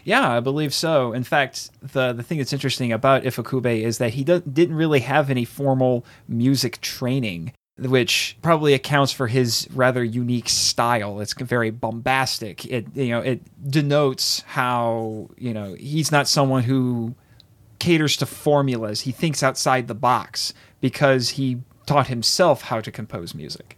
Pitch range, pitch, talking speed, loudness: 120-140 Hz, 130 Hz, 160 wpm, -21 LUFS